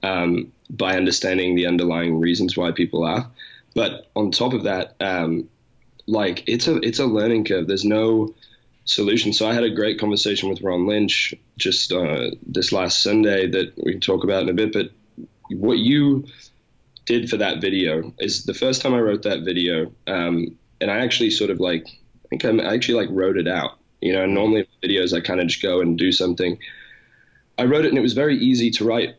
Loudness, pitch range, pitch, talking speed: -20 LUFS, 90-115 Hz, 100 Hz, 205 wpm